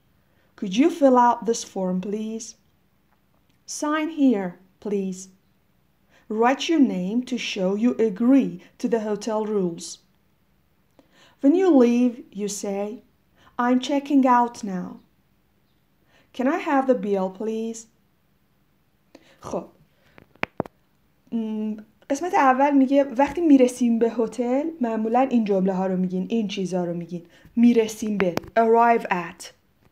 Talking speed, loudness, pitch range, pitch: 115 wpm, -22 LUFS, 200-255 Hz, 230 Hz